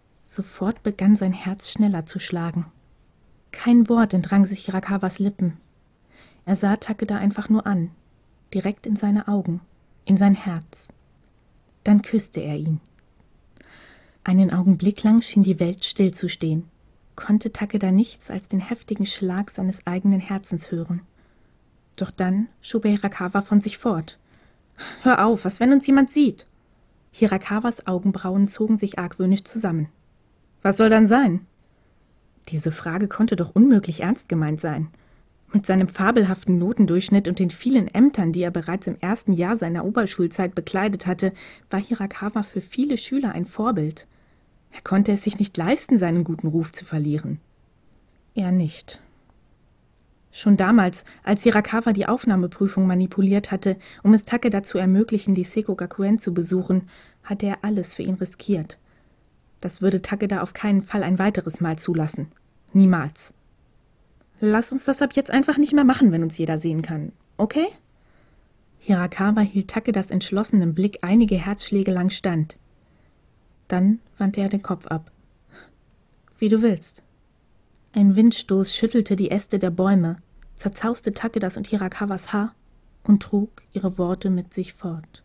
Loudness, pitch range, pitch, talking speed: -22 LUFS, 180-215 Hz, 195 Hz, 145 wpm